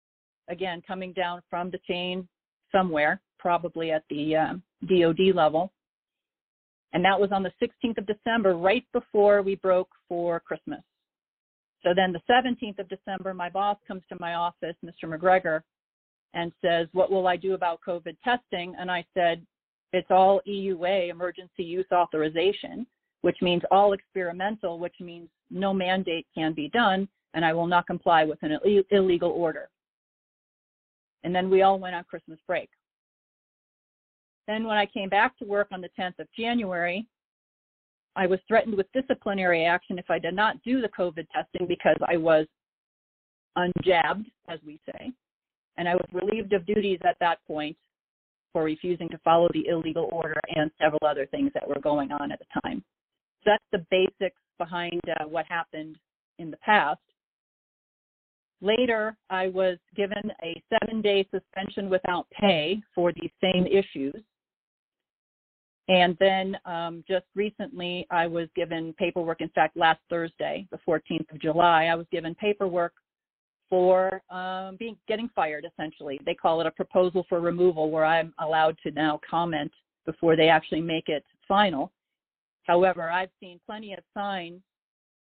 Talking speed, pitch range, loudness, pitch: 160 wpm, 165-195 Hz, -26 LUFS, 180 Hz